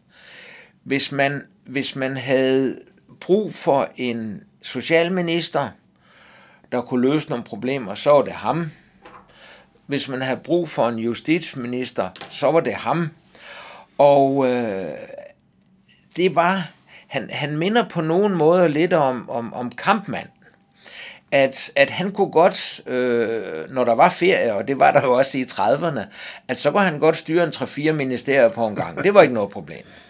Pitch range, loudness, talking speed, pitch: 130-170 Hz, -20 LUFS, 160 wpm, 140 Hz